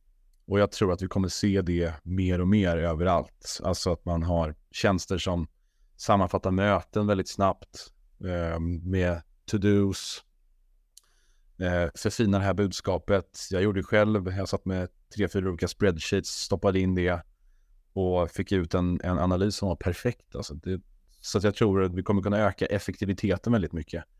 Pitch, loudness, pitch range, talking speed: 95 Hz, -27 LUFS, 85-100 Hz, 165 wpm